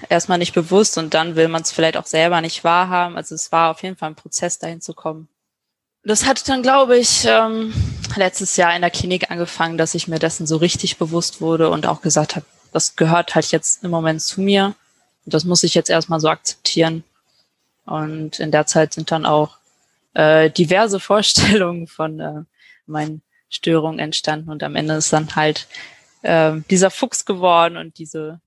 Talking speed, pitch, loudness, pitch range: 190 wpm, 165 Hz, -17 LUFS, 155-180 Hz